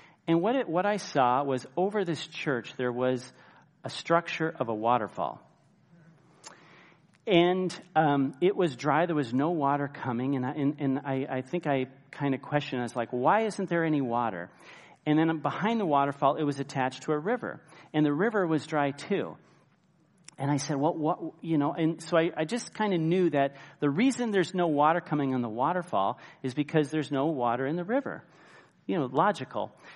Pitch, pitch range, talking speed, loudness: 150 Hz, 135-175 Hz, 200 wpm, -29 LUFS